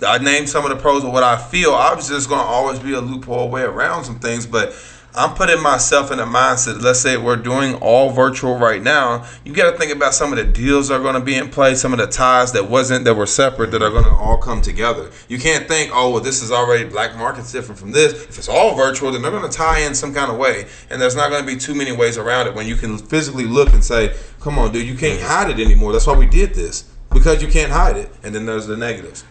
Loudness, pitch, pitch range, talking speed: -16 LUFS, 130 Hz, 115-140 Hz, 270 wpm